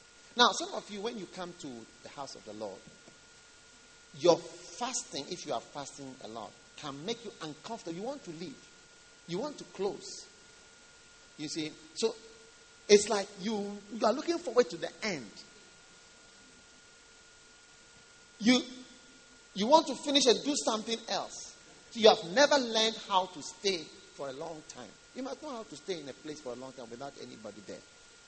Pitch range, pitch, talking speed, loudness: 165-250 Hz, 210 Hz, 175 wpm, -31 LUFS